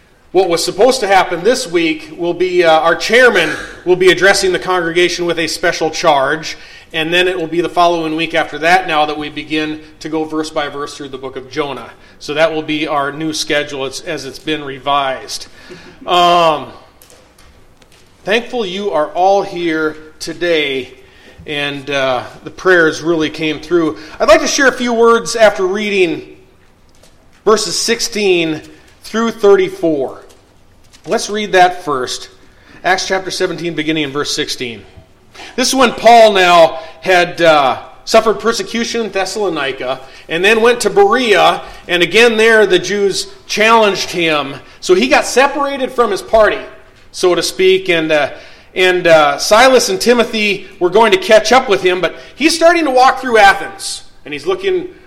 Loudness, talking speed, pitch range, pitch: -12 LUFS, 165 wpm, 155-225 Hz, 180 Hz